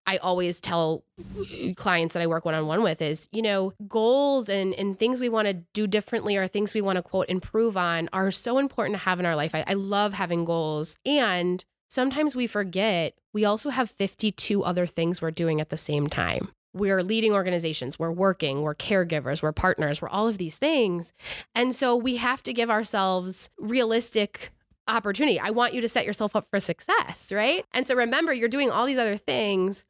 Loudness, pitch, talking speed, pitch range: -26 LUFS, 195 Hz, 200 wpm, 175-230 Hz